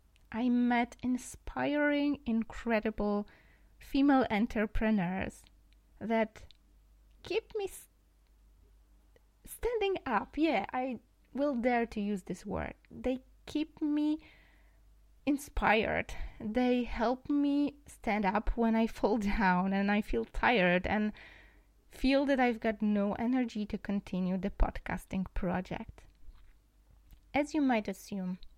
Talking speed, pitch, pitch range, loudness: 110 wpm, 225 Hz, 200-265 Hz, -32 LUFS